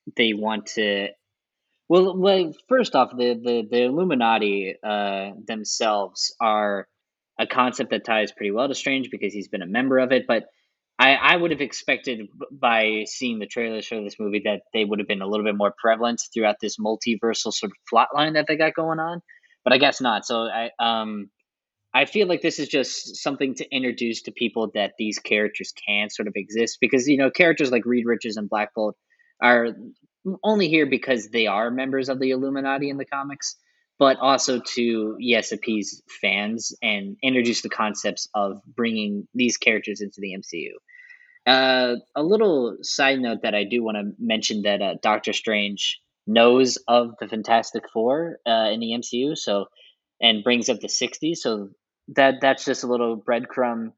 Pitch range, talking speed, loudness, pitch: 105-135 Hz, 180 wpm, -22 LUFS, 120 Hz